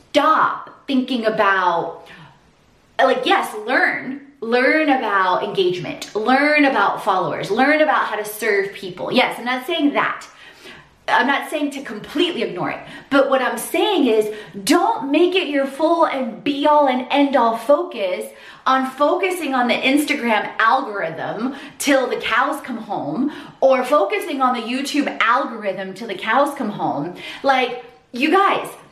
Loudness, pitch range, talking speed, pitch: -18 LUFS, 230-295 Hz, 150 wpm, 270 Hz